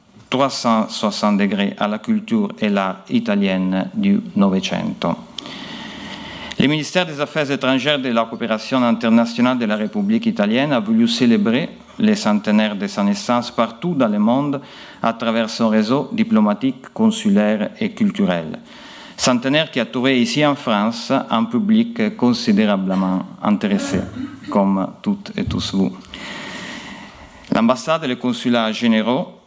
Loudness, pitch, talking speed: -18 LUFS, 140 Hz, 130 wpm